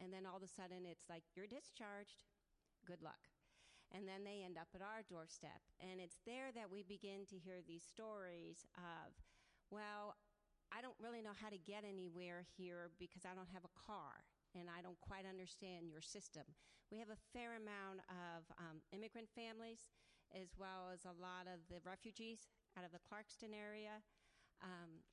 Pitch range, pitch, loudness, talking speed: 175-210 Hz, 185 Hz, -57 LUFS, 185 wpm